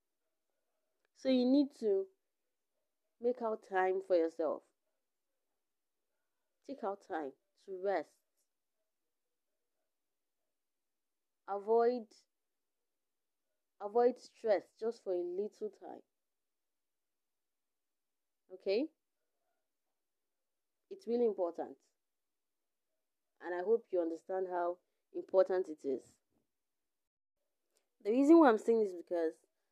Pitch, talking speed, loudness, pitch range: 220 Hz, 85 wpm, -35 LUFS, 185-275 Hz